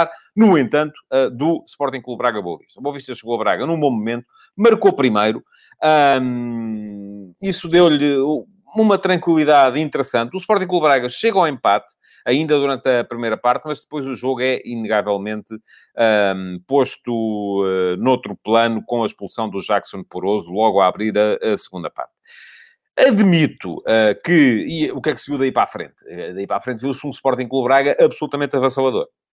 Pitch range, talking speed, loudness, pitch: 110-150 Hz, 160 wpm, -18 LUFS, 130 Hz